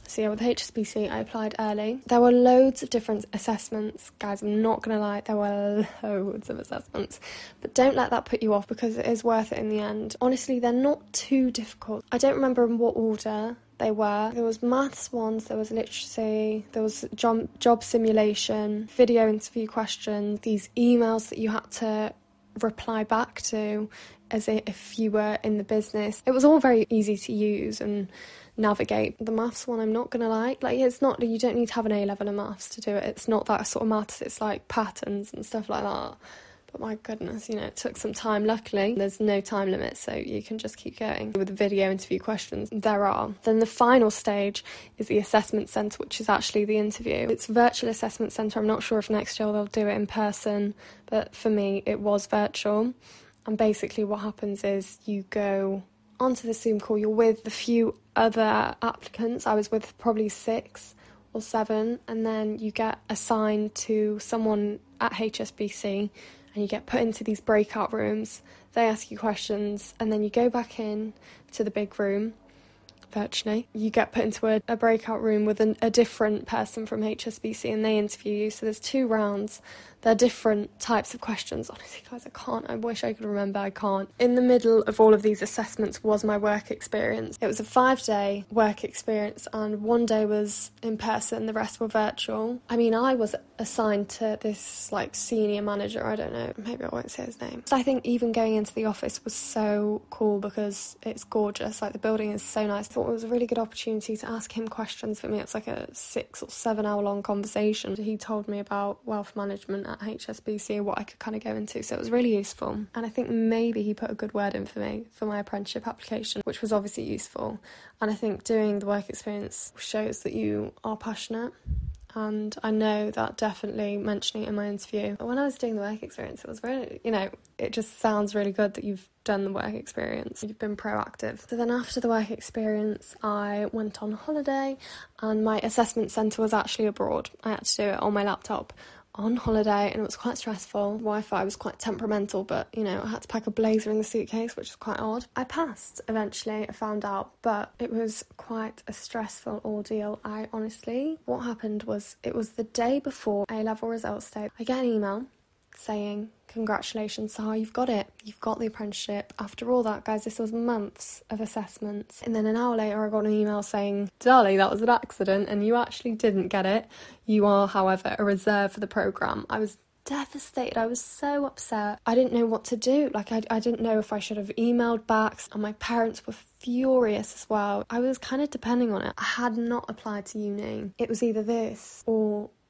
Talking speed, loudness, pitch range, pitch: 210 wpm, -27 LUFS, 210-230 Hz, 215 Hz